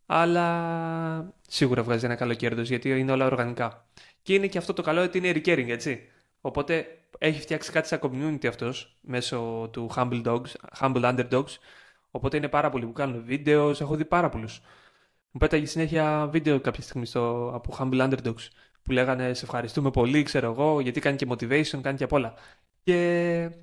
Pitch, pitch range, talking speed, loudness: 135 Hz, 120-155 Hz, 180 wpm, -27 LUFS